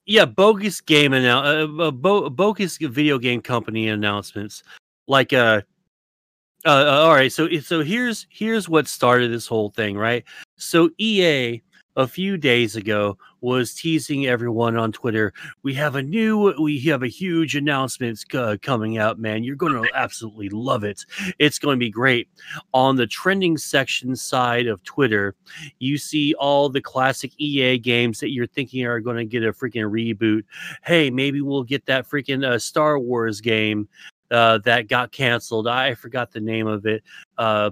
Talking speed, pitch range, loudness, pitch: 165 wpm, 115-150 Hz, -20 LUFS, 125 Hz